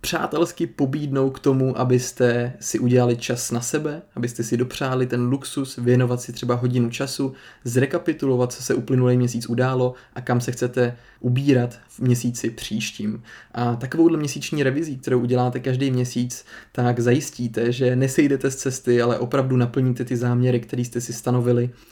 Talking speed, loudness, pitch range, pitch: 155 wpm, -22 LUFS, 120-135 Hz, 125 Hz